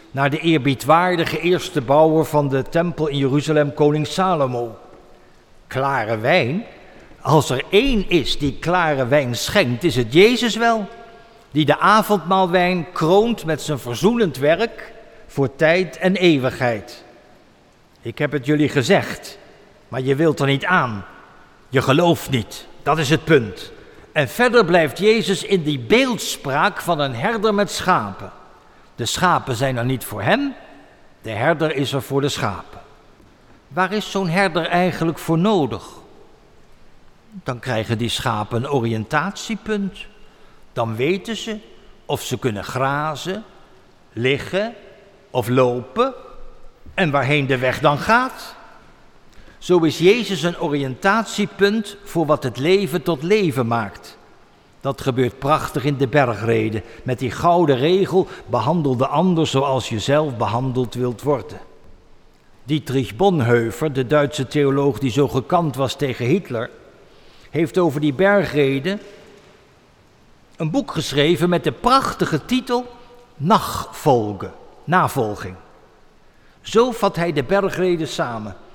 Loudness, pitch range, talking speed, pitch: -19 LUFS, 135-195 Hz, 130 wpm, 155 Hz